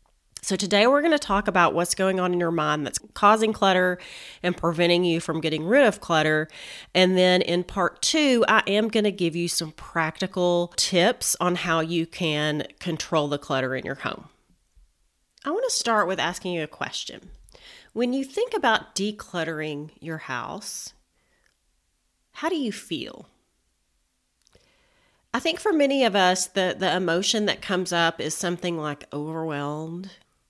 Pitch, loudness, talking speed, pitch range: 175 Hz, -24 LUFS, 165 wpm, 160-205 Hz